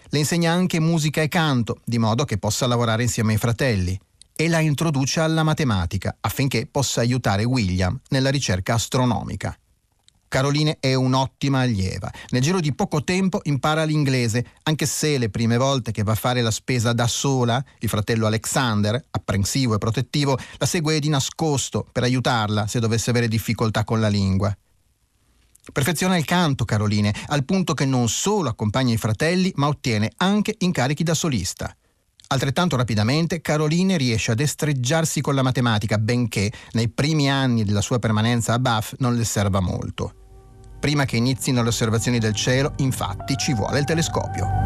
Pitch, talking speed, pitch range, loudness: 125 Hz, 165 wpm, 110-145 Hz, -21 LUFS